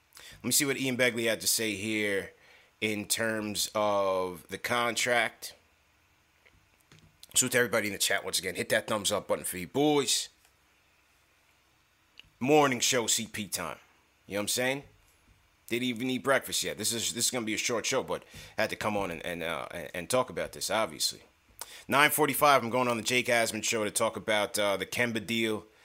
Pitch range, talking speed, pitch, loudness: 100-125 Hz, 195 wpm, 115 Hz, -29 LUFS